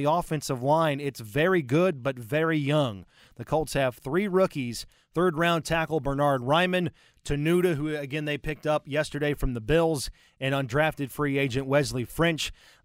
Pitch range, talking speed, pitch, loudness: 135-160 Hz, 165 wpm, 150 Hz, -27 LUFS